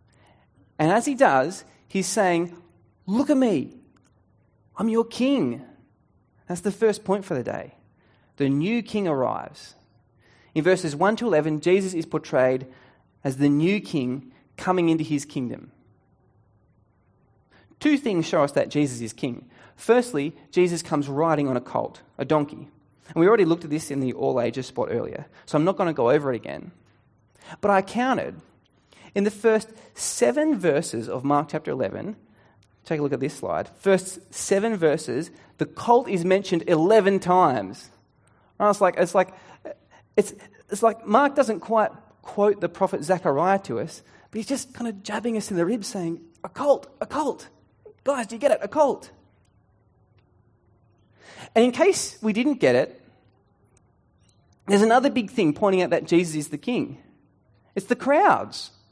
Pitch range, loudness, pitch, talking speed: 140-220 Hz, -23 LUFS, 180 Hz, 165 wpm